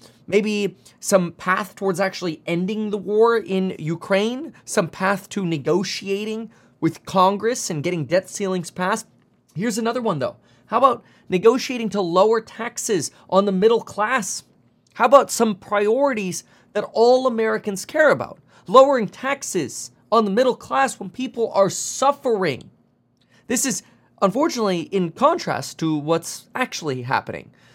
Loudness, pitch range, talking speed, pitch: -21 LUFS, 185-230 Hz, 135 wpm, 205 Hz